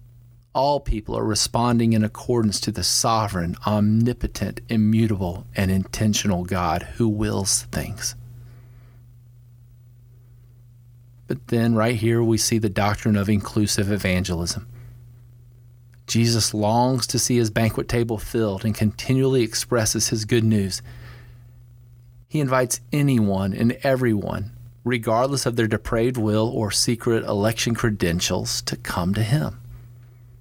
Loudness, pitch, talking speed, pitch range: -22 LUFS, 115 Hz, 120 wpm, 110-120 Hz